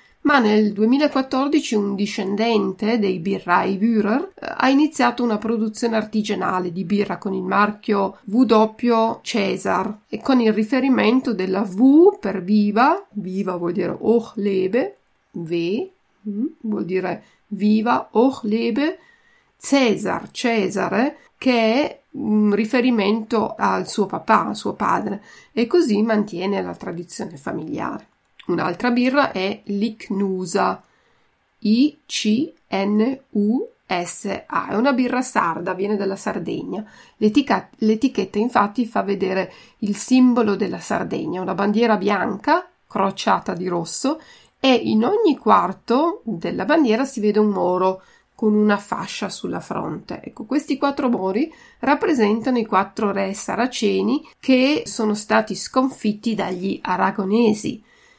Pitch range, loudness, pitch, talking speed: 200-255 Hz, -20 LUFS, 220 Hz, 120 wpm